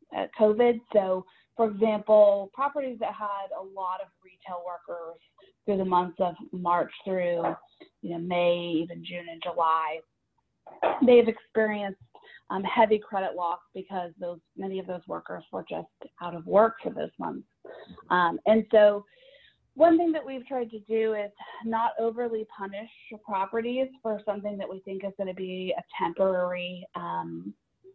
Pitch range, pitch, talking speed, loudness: 175-220 Hz, 195 Hz, 160 wpm, -27 LUFS